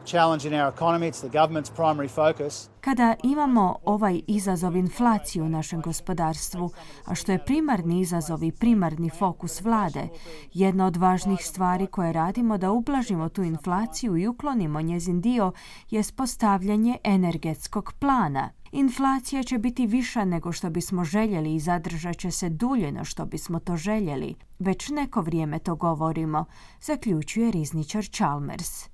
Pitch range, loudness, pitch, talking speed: 165-220 Hz, -26 LUFS, 180 Hz, 125 wpm